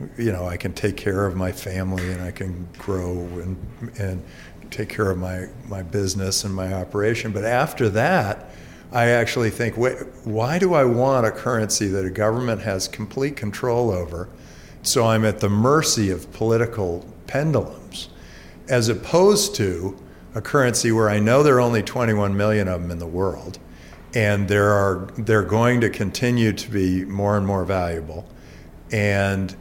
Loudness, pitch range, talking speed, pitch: -21 LUFS, 90-115 Hz, 170 wpm, 100 Hz